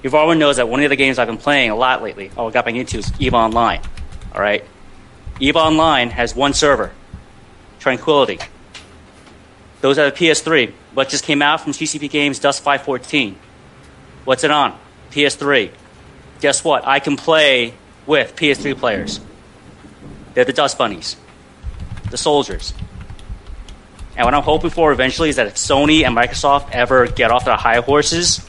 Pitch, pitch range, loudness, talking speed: 135 Hz, 115-145 Hz, -15 LUFS, 165 wpm